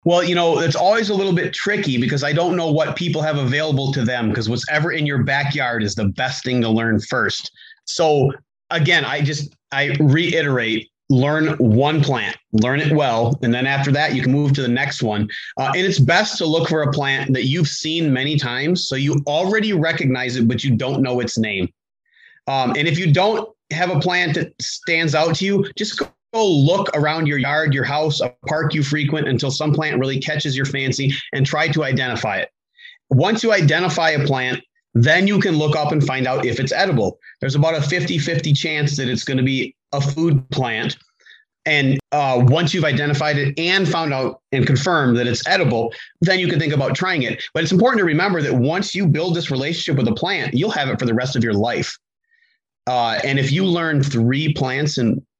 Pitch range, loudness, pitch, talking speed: 130-165 Hz, -18 LUFS, 145 Hz, 215 wpm